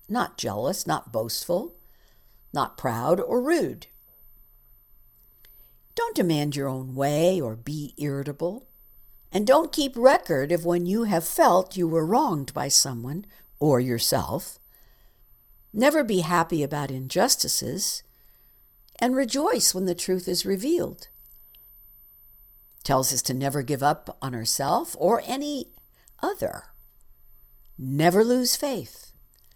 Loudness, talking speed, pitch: -24 LUFS, 120 wpm, 170 Hz